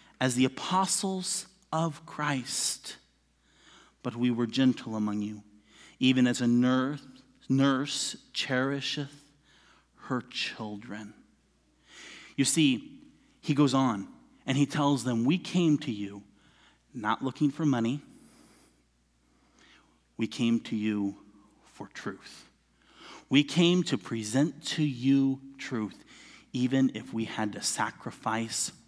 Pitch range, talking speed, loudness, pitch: 110-145 Hz, 110 wpm, -29 LUFS, 130 Hz